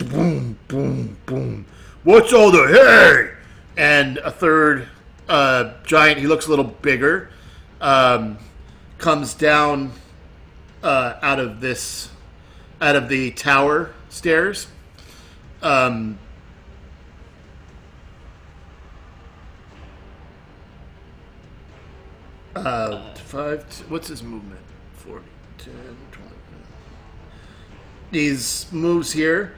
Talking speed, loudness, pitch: 80 wpm, -16 LUFS, 100 Hz